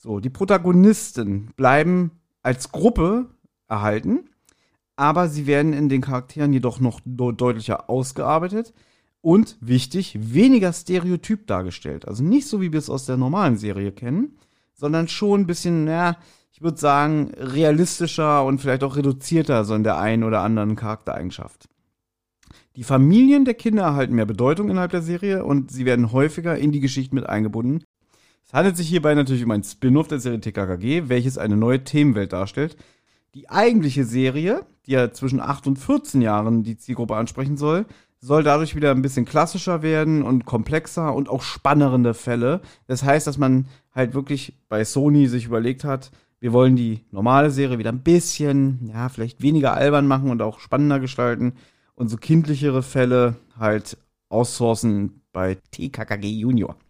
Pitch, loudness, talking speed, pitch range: 135 Hz, -20 LUFS, 160 wpm, 120-155 Hz